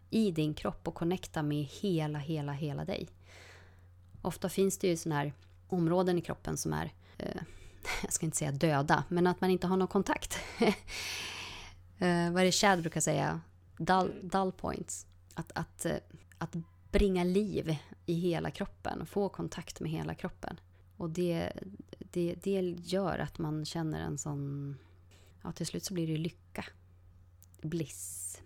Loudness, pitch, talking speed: -34 LUFS, 155 Hz, 160 wpm